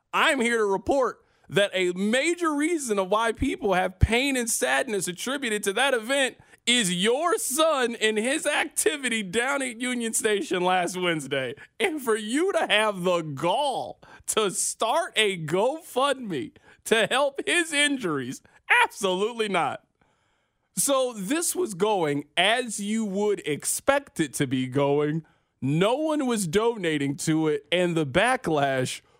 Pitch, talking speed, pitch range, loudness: 220 Hz, 140 wpm, 180-275 Hz, -25 LUFS